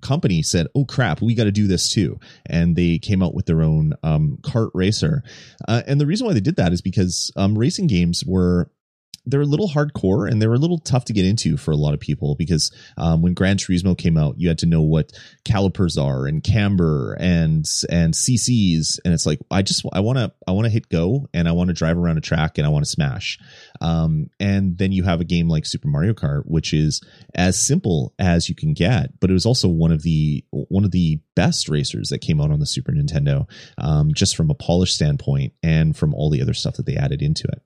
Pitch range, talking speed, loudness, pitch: 80-130 Hz, 240 wpm, -19 LUFS, 95 Hz